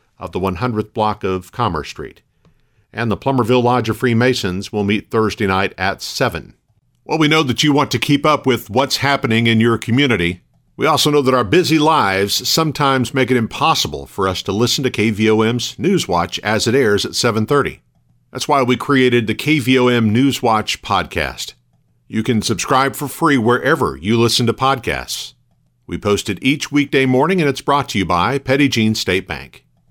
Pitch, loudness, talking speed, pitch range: 120 Hz, -16 LUFS, 185 wpm, 105-135 Hz